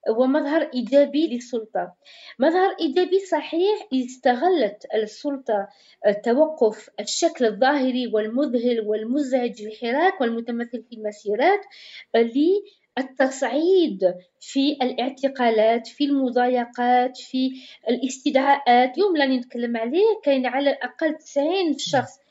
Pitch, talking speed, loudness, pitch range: 260 Hz, 90 wpm, -22 LUFS, 235-300 Hz